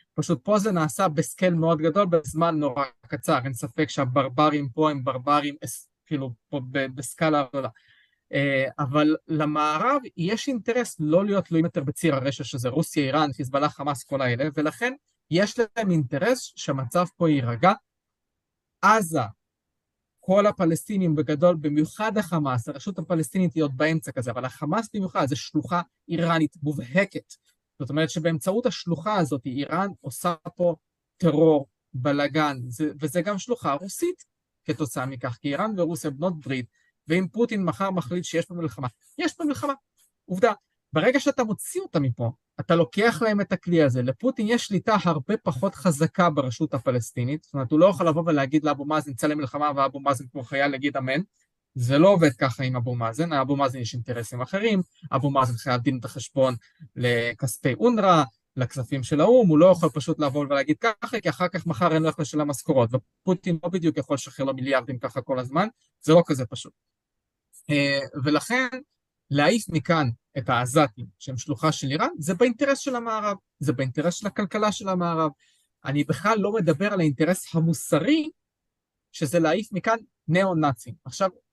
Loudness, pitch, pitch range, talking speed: -24 LUFS, 155 Hz, 140-180 Hz, 160 wpm